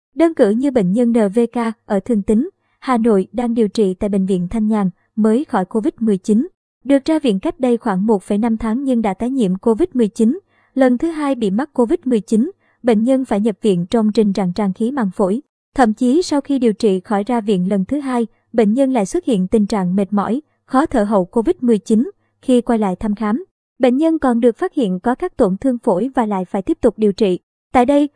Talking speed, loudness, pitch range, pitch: 220 wpm, -17 LUFS, 210-255 Hz, 230 Hz